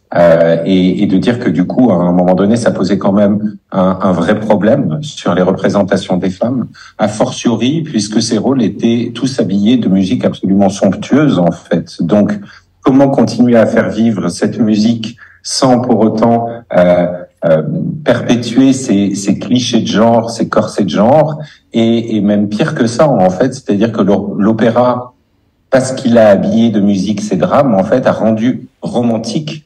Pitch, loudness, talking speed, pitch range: 115 Hz, -11 LUFS, 175 wpm, 100-125 Hz